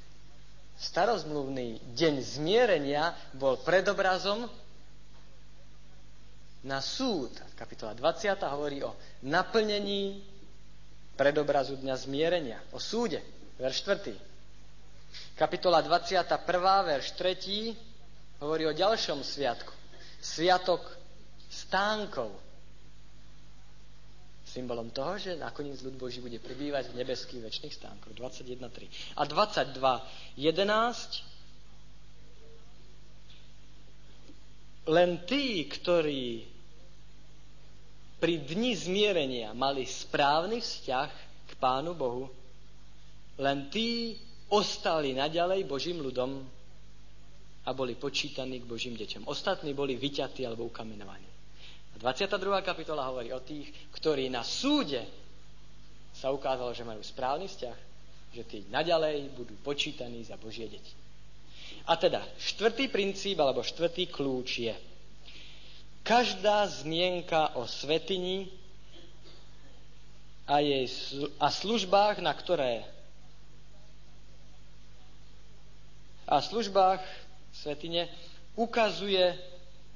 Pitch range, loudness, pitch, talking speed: 130-175 Hz, -31 LUFS, 145 Hz, 90 wpm